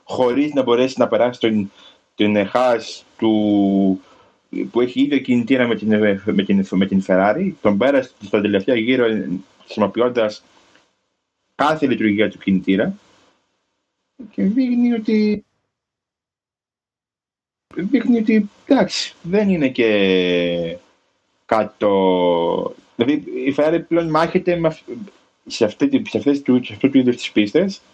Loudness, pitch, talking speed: -18 LUFS, 125 Hz, 110 wpm